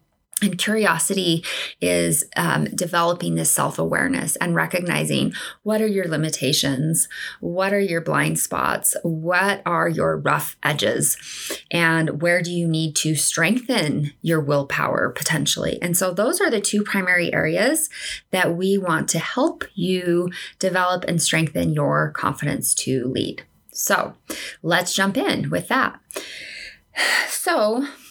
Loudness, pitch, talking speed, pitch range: -21 LUFS, 175 Hz, 130 wpm, 155-195 Hz